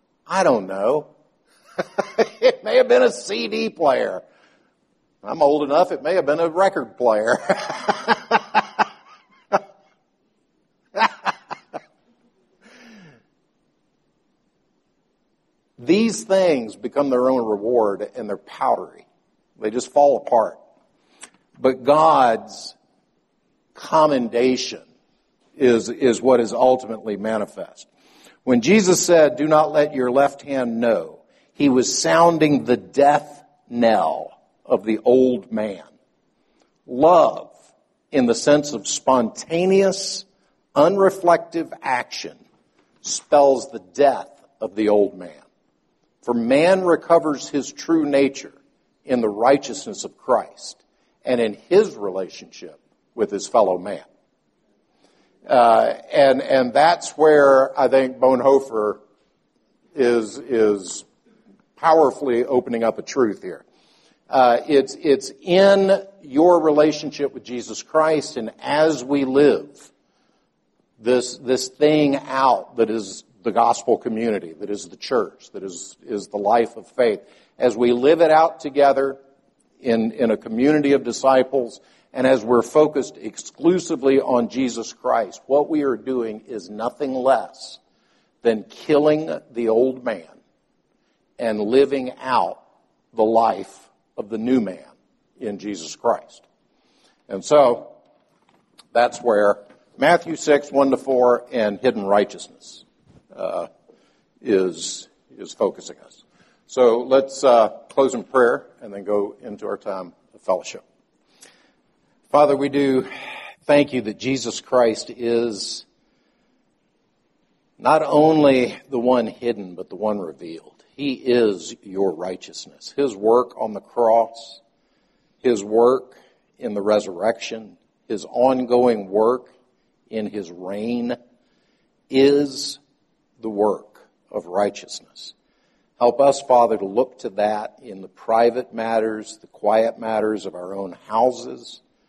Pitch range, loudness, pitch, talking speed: 115-145 Hz, -19 LUFS, 130 Hz, 120 wpm